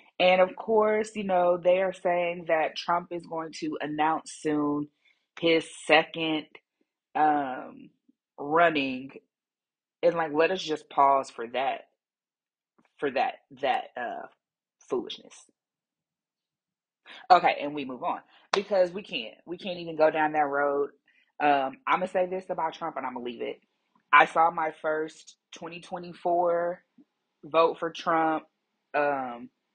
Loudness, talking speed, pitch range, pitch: -27 LUFS, 135 wpm, 150-180 Hz, 165 Hz